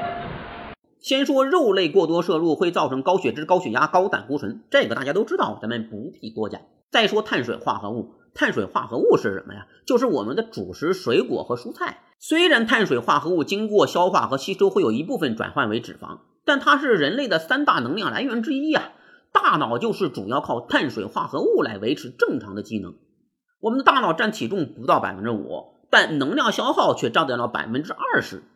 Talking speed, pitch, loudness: 315 characters per minute, 270 Hz, -22 LUFS